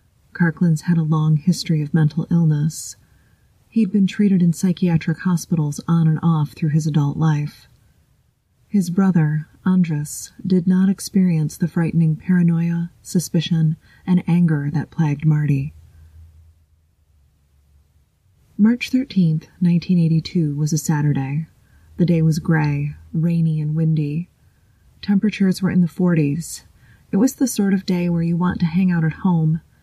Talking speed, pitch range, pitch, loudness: 135 wpm, 150-180 Hz, 165 Hz, -19 LUFS